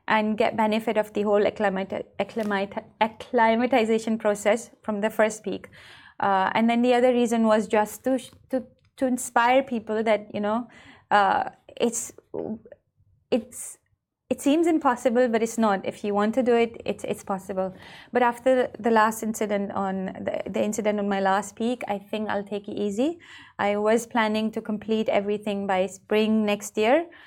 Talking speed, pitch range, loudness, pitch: 165 wpm, 205-240 Hz, -25 LUFS, 220 Hz